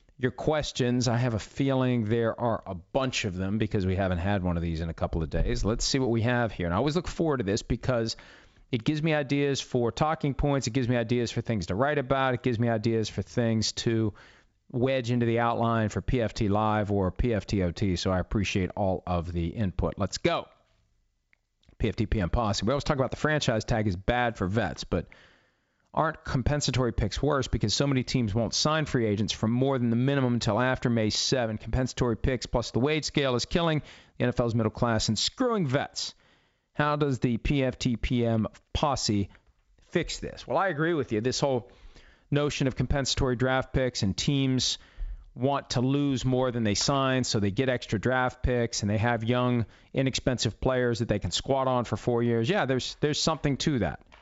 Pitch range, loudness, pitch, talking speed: 105-130 Hz, -28 LUFS, 120 Hz, 205 wpm